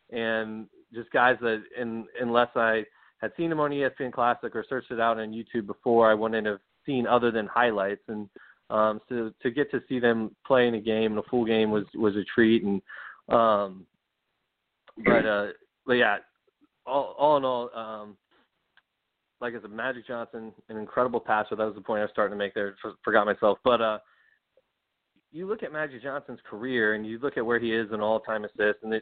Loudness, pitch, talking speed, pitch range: -27 LUFS, 115 Hz, 210 wpm, 110-125 Hz